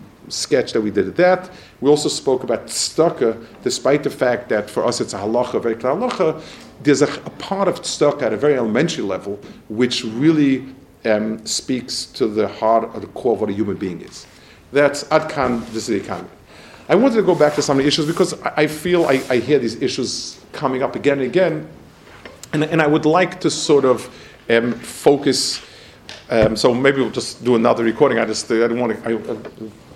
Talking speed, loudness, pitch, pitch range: 205 wpm, -18 LUFS, 140 Hz, 115-155 Hz